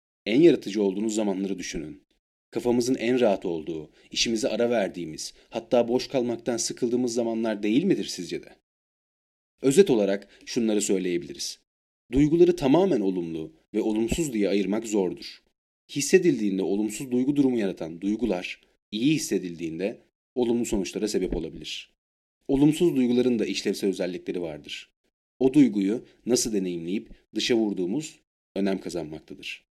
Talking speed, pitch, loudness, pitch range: 120 wpm, 115 Hz, -25 LUFS, 100-125 Hz